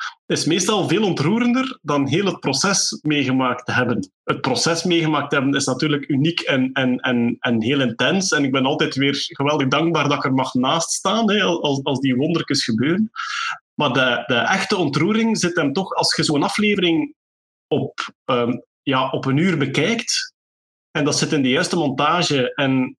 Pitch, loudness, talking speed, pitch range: 145 Hz, -19 LUFS, 185 wpm, 135-175 Hz